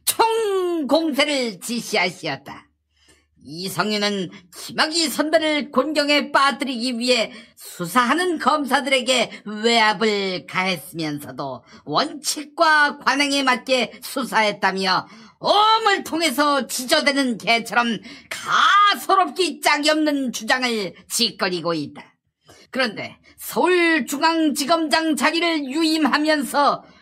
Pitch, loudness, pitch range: 265 Hz, -19 LUFS, 210-310 Hz